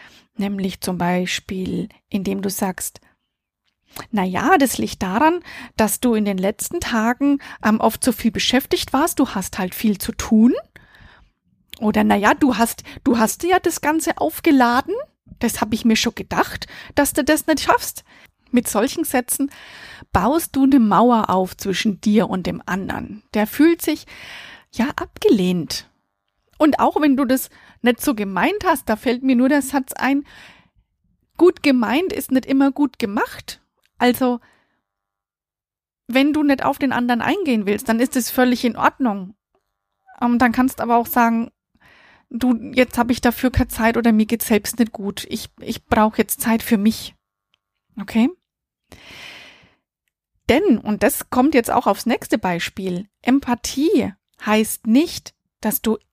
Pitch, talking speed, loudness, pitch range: 240 Hz, 160 wpm, -19 LUFS, 210-275 Hz